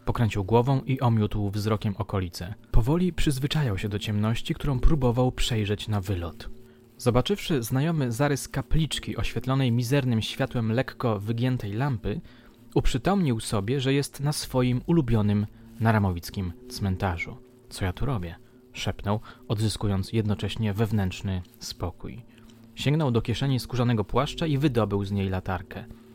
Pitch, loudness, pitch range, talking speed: 115 Hz, -27 LUFS, 105-130 Hz, 125 wpm